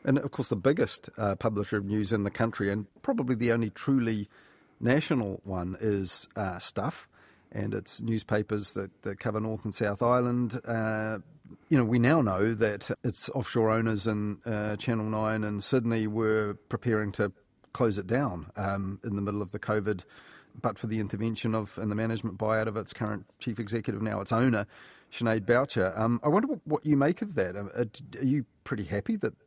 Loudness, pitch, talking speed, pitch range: -30 LUFS, 110 Hz, 190 wpm, 105-120 Hz